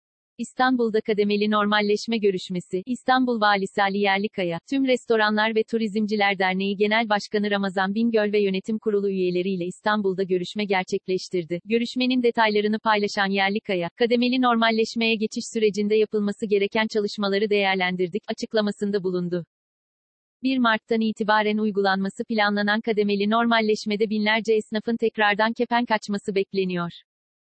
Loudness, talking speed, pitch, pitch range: -23 LUFS, 110 wpm, 210 Hz, 200-225 Hz